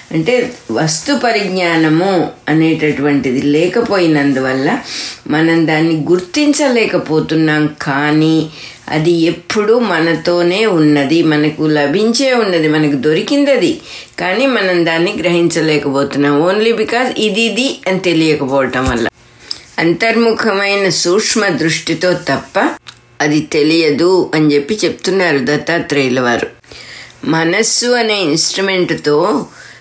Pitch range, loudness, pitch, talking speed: 150-195 Hz, -13 LUFS, 165 Hz, 85 wpm